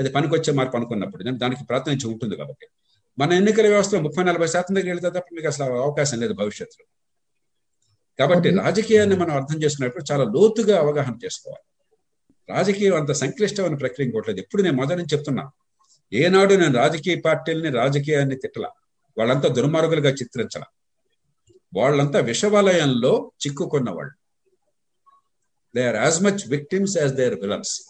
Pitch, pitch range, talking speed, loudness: 160 Hz, 140-200 Hz, 135 wpm, -21 LUFS